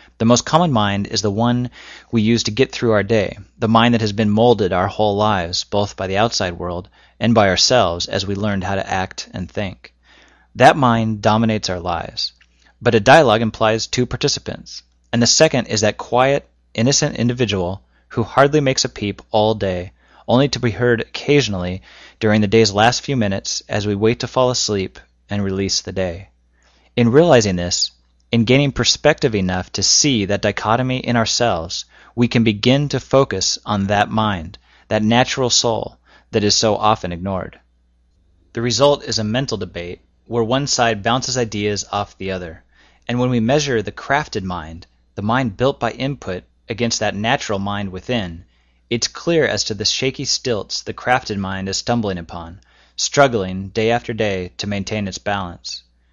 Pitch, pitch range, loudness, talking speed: 110 Hz, 95-120 Hz, -17 LUFS, 180 wpm